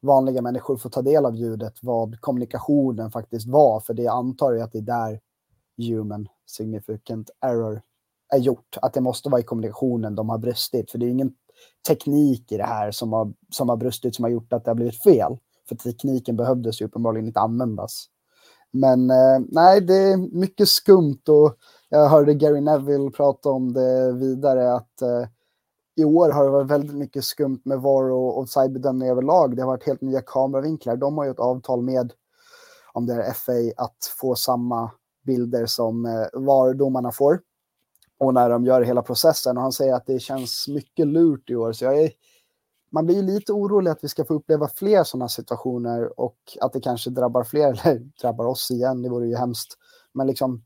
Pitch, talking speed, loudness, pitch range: 130 Hz, 195 wpm, -21 LUFS, 120-140 Hz